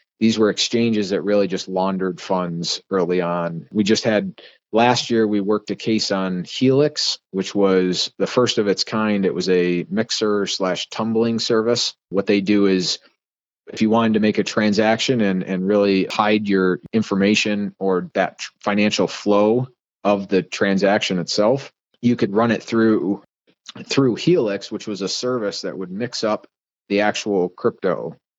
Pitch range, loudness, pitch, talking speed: 95-110 Hz, -20 LUFS, 105 Hz, 165 wpm